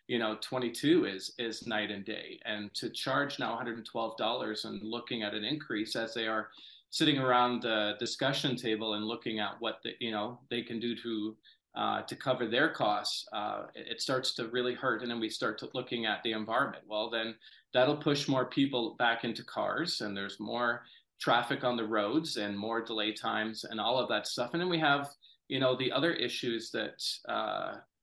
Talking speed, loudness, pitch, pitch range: 200 wpm, -33 LUFS, 115 Hz, 110-125 Hz